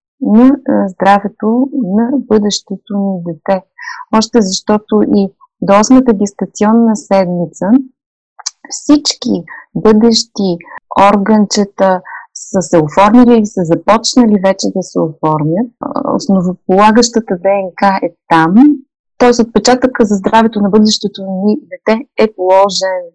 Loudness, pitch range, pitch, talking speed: -11 LUFS, 195-240 Hz, 210 Hz, 100 wpm